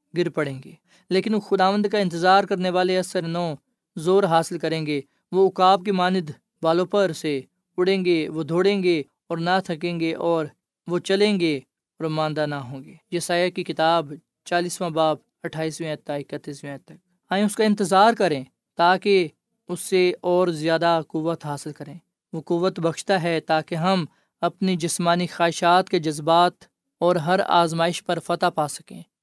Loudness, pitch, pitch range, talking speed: -22 LUFS, 175 Hz, 160-185 Hz, 165 wpm